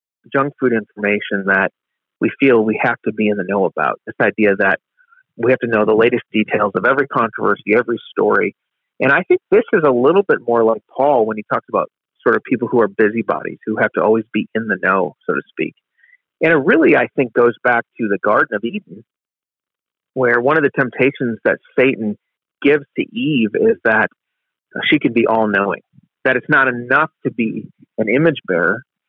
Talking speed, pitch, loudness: 205 wpm, 125 Hz, -16 LUFS